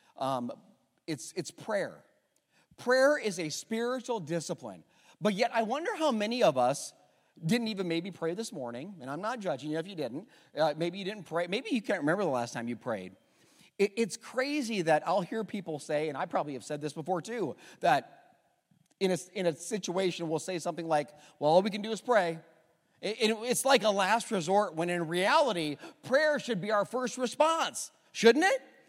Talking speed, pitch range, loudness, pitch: 210 wpm, 165-230 Hz, -31 LUFS, 195 Hz